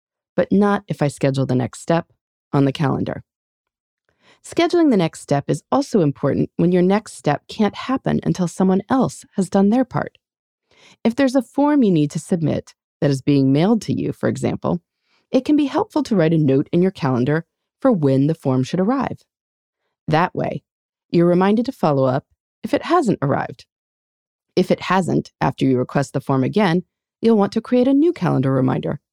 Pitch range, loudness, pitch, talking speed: 140-235 Hz, -19 LUFS, 180 Hz, 190 wpm